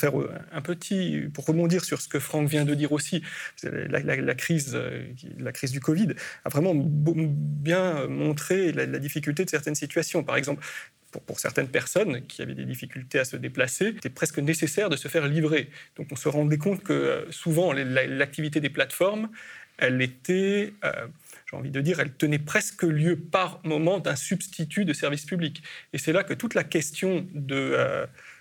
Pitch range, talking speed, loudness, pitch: 145-180 Hz, 185 wpm, -27 LUFS, 155 Hz